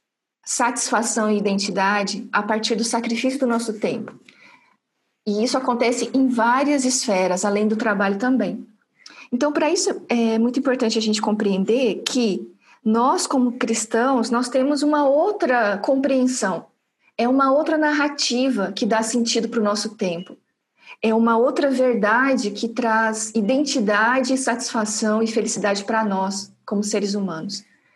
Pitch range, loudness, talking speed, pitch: 215-260 Hz, -20 LUFS, 135 wpm, 230 Hz